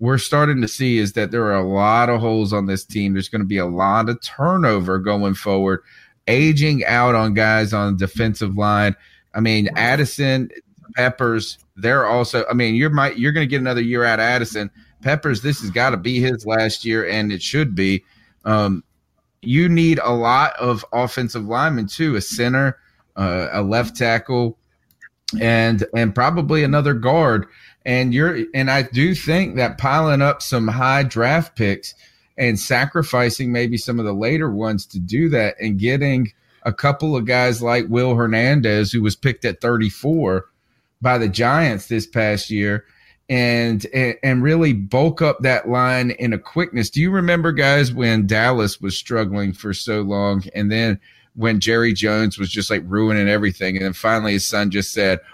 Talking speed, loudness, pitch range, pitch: 180 wpm, -18 LUFS, 105-130 Hz, 115 Hz